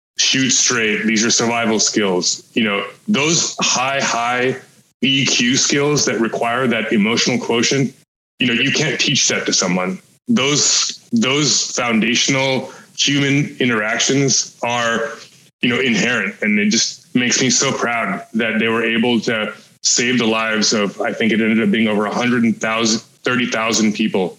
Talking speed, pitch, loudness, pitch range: 160 wpm, 115 Hz, -16 LUFS, 110-135 Hz